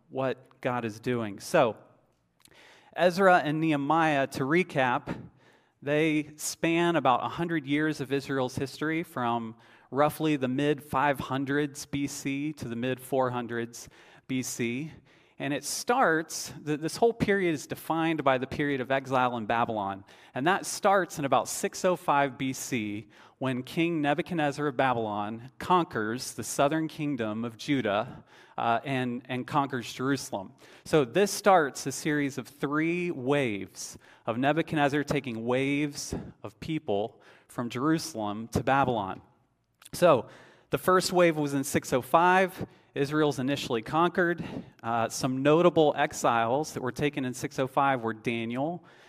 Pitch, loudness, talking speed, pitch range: 140 Hz, -28 LUFS, 130 wpm, 125-155 Hz